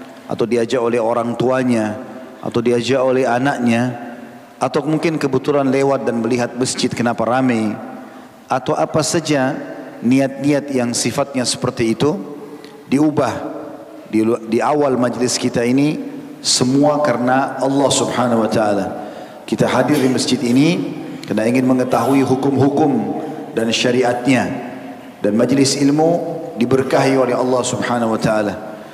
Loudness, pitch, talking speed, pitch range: -17 LUFS, 125 Hz, 120 wpm, 120-140 Hz